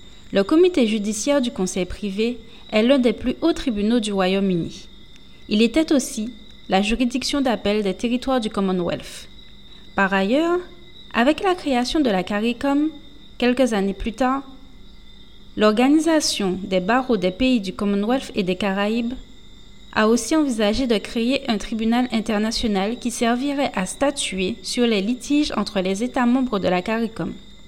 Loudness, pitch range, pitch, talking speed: -21 LUFS, 205-260 Hz, 230 Hz, 145 wpm